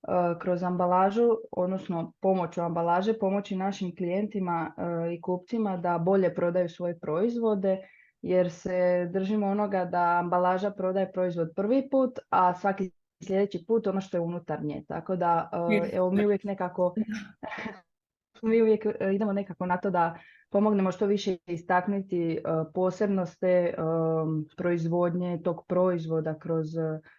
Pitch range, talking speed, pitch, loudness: 175-200 Hz, 125 wpm, 180 Hz, -28 LUFS